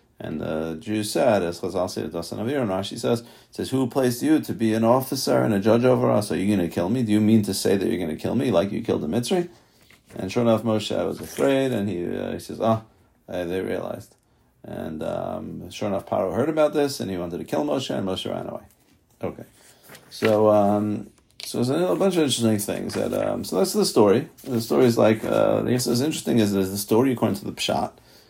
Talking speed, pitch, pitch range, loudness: 230 wpm, 110 Hz, 100-125 Hz, -23 LUFS